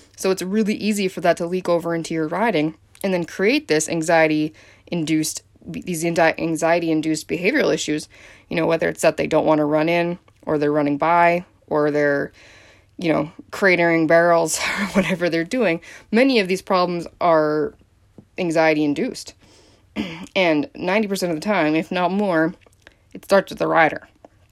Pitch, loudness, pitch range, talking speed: 165 Hz, -20 LUFS, 150-180 Hz, 165 wpm